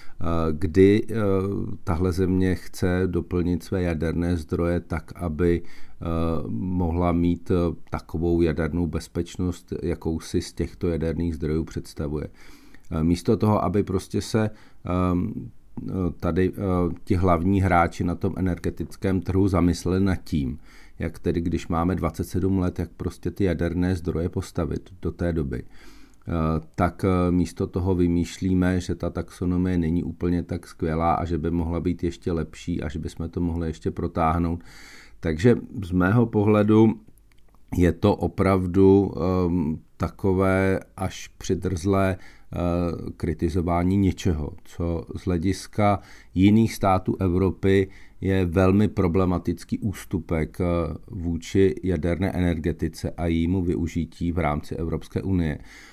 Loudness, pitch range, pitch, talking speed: -24 LUFS, 85-95 Hz, 90 Hz, 120 wpm